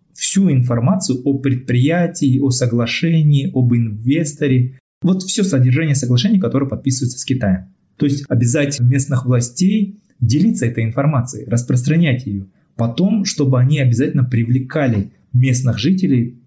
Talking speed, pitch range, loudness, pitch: 120 wpm, 125-150 Hz, -16 LUFS, 130 Hz